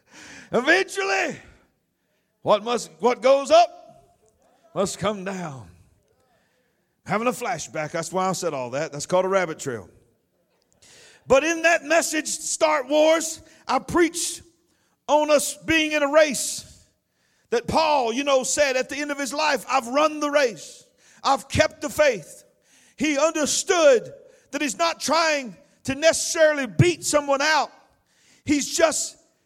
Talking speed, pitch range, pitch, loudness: 140 wpm, 240-320 Hz, 290 Hz, -22 LUFS